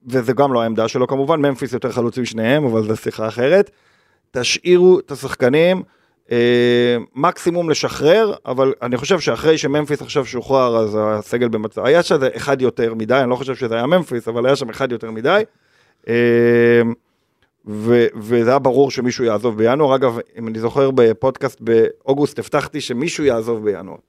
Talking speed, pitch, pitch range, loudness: 160 wpm, 125 Hz, 115-140 Hz, -17 LUFS